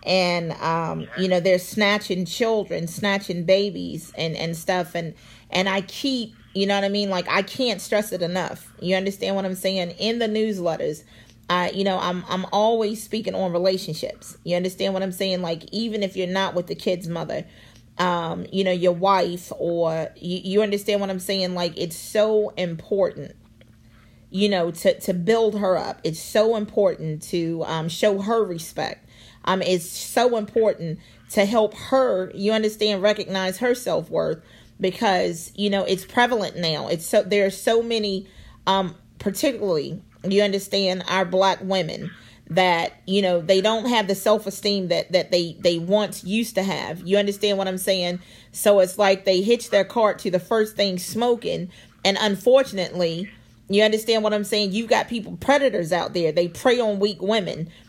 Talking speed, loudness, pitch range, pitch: 175 wpm, -22 LUFS, 175-210 Hz, 190 Hz